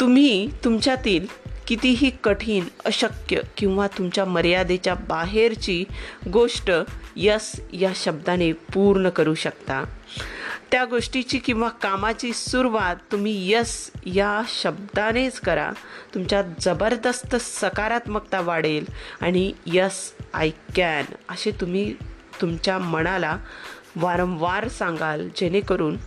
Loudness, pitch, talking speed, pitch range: -23 LUFS, 200 Hz, 95 wpm, 180-230 Hz